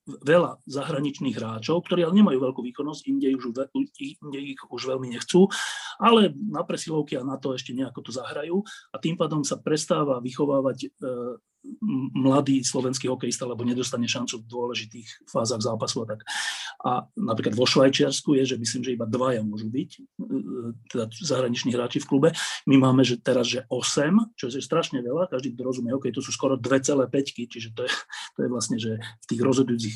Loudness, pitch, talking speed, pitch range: -25 LUFS, 135 Hz, 180 wpm, 125-150 Hz